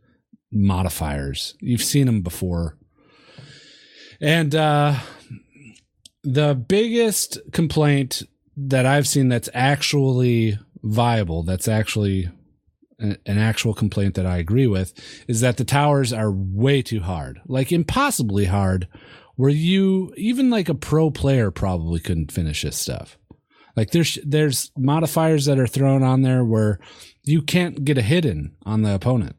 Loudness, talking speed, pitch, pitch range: -20 LUFS, 135 wpm, 125 Hz, 100-145 Hz